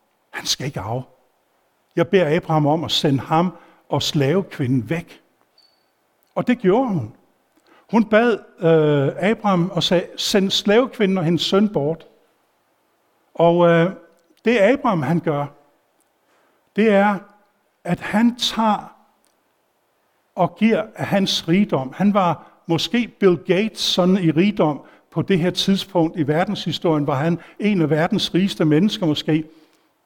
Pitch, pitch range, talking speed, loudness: 175 Hz, 160-205 Hz, 135 wpm, -19 LUFS